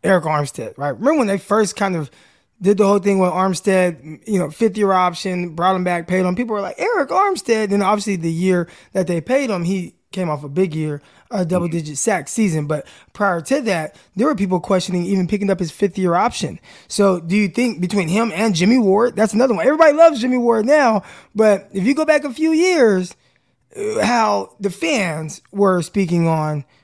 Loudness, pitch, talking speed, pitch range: -18 LUFS, 195 Hz, 210 wpm, 180-220 Hz